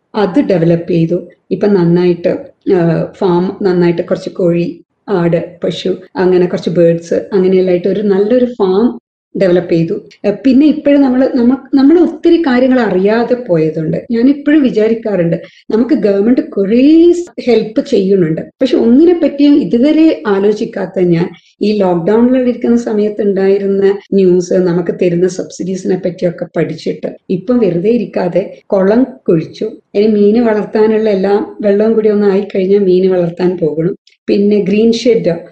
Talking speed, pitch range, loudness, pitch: 120 wpm, 180-235 Hz, -11 LUFS, 200 Hz